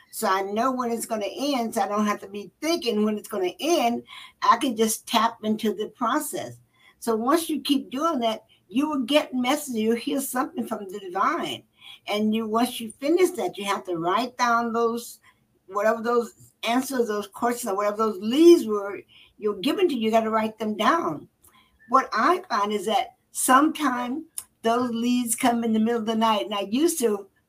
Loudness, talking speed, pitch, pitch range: -24 LUFS, 205 wpm, 230 Hz, 215-265 Hz